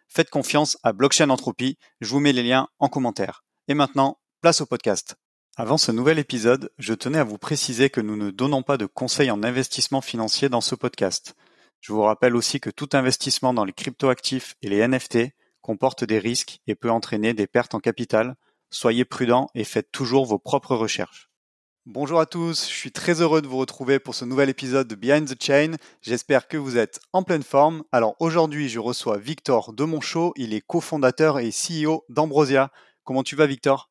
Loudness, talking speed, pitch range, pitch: -22 LUFS, 200 wpm, 120-145 Hz, 130 Hz